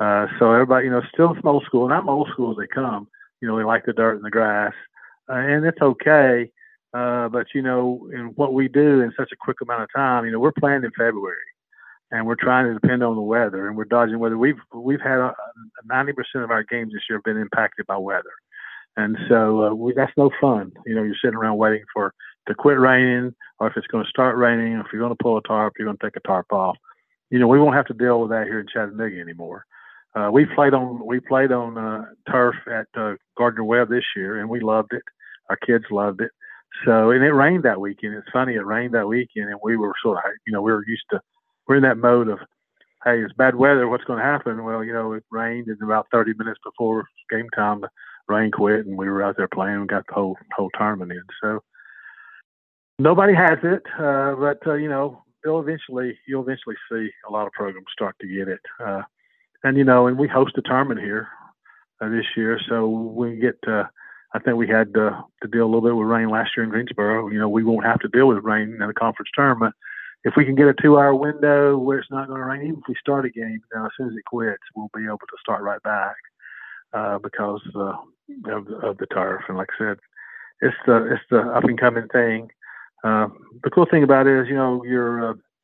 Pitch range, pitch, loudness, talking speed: 110-135 Hz, 120 Hz, -20 LUFS, 240 wpm